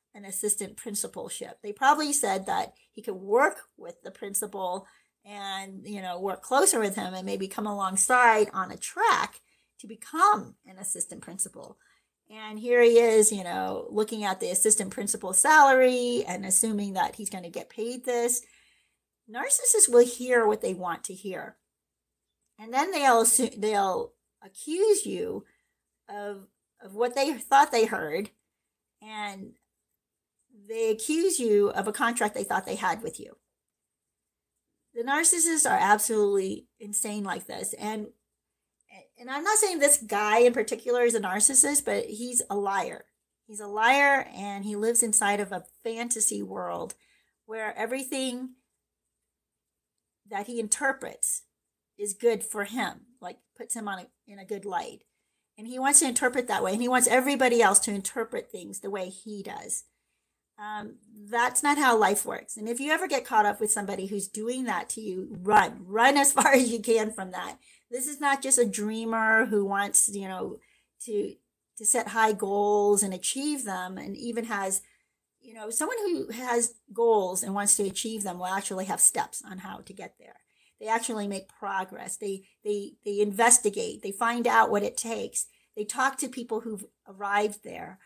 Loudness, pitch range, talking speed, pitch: -25 LUFS, 200-250 Hz, 170 wpm, 220 Hz